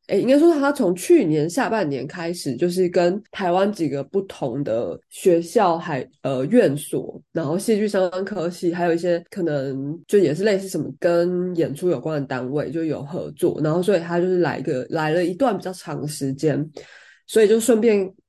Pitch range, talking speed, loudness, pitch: 155-190 Hz, 290 characters per minute, -21 LUFS, 175 Hz